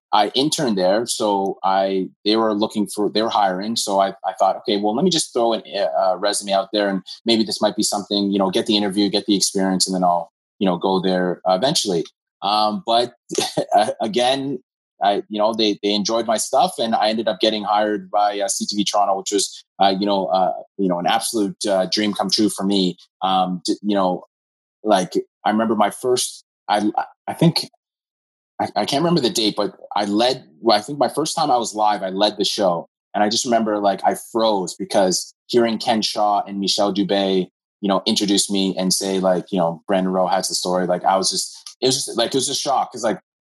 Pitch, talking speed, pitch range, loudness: 100 Hz, 220 wpm, 95-110 Hz, -19 LUFS